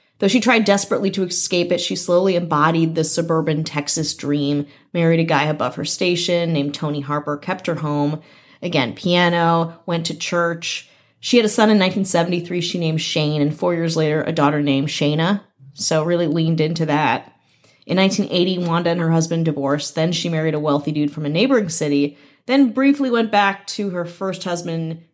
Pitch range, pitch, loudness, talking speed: 150-180 Hz, 165 Hz, -19 LUFS, 185 wpm